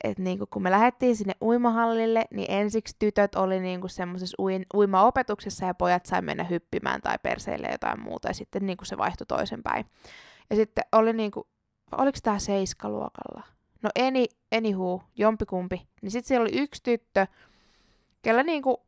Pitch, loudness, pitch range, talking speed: 210 Hz, -27 LUFS, 185-230 Hz, 155 wpm